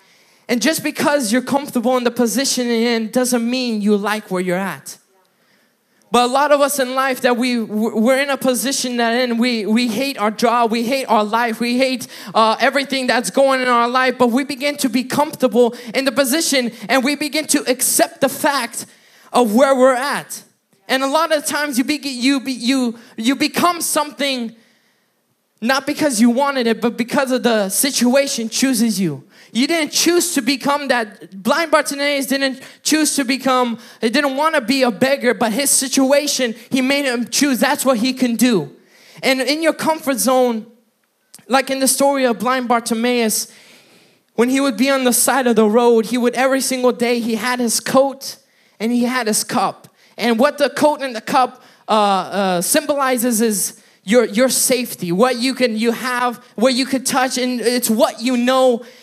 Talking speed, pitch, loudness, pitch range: 195 wpm, 255 Hz, -17 LUFS, 235-275 Hz